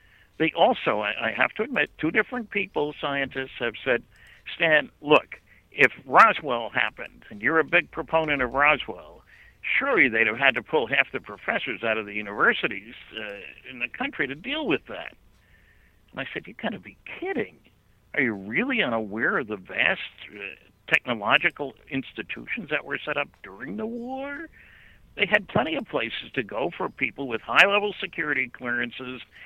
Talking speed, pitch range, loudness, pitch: 170 wpm, 120-175 Hz, -24 LUFS, 145 Hz